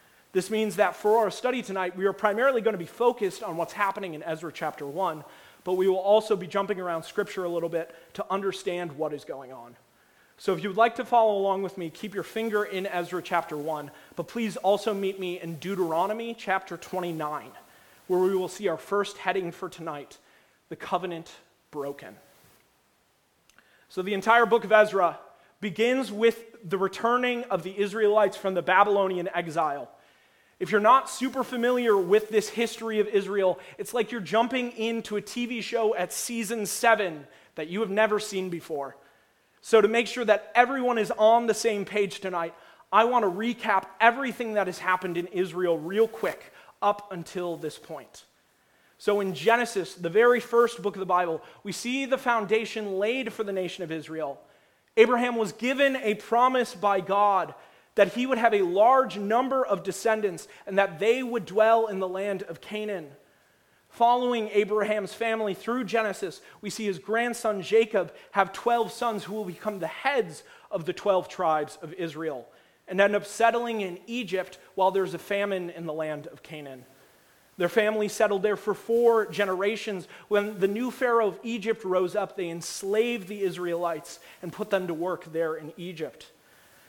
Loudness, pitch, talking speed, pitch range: -26 LUFS, 200 Hz, 180 wpm, 180-225 Hz